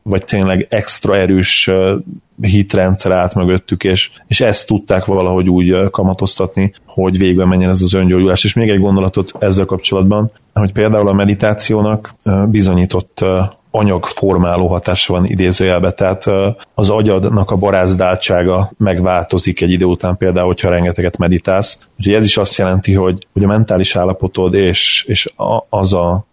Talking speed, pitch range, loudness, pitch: 145 wpm, 90-100 Hz, -13 LUFS, 95 Hz